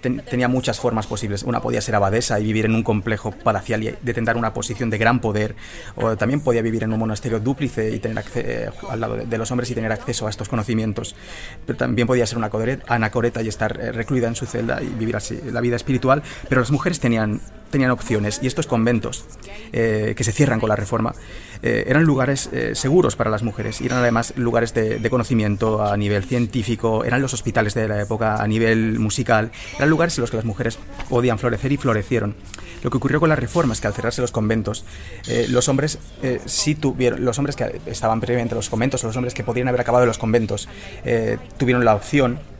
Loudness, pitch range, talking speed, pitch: -21 LUFS, 110-125 Hz, 215 wpm, 115 Hz